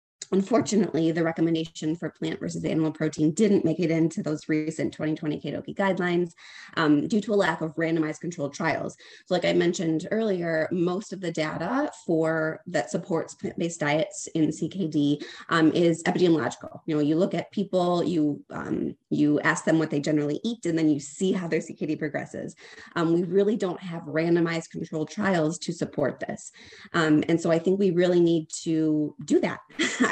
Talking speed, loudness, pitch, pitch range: 180 wpm, -26 LUFS, 165 Hz, 155-180 Hz